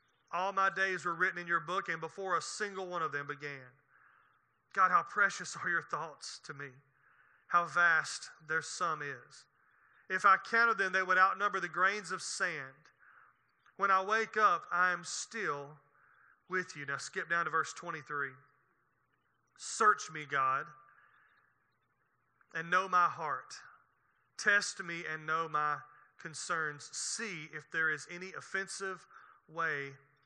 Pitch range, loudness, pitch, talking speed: 150-190 Hz, -33 LUFS, 170 Hz, 150 wpm